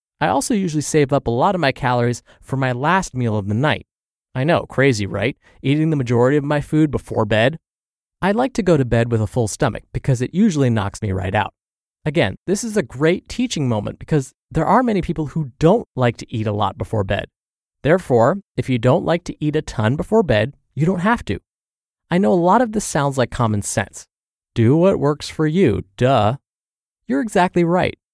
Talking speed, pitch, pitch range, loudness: 215 wpm, 140 Hz, 115-175 Hz, -19 LUFS